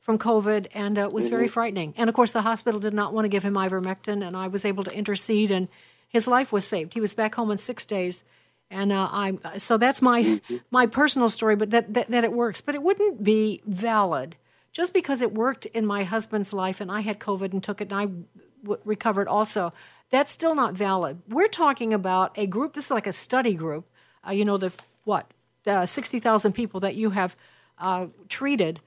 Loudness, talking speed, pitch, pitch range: -24 LUFS, 220 wpm, 210 Hz, 195-230 Hz